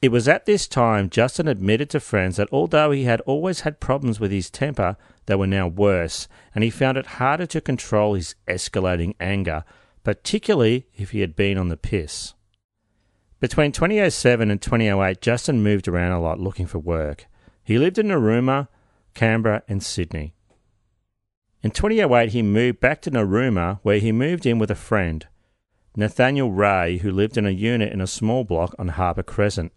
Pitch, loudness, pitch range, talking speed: 105 Hz, -21 LUFS, 95-125 Hz, 175 wpm